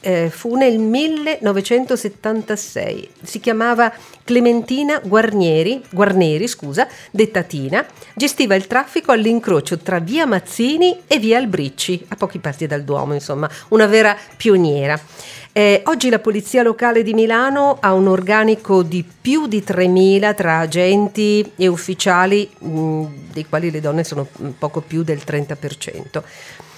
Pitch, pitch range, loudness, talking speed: 205 Hz, 165-230 Hz, -16 LUFS, 130 wpm